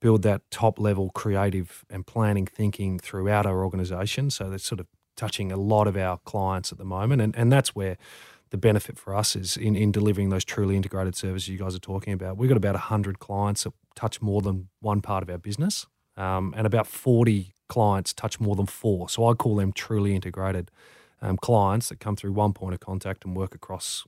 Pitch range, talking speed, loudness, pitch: 95-110 Hz, 215 wpm, -26 LUFS, 100 Hz